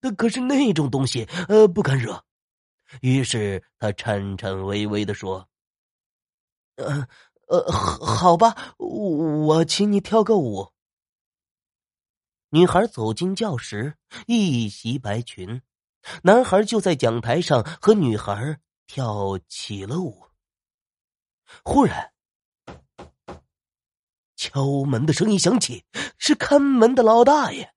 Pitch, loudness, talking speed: 140 Hz, -21 LUFS, 150 characters per minute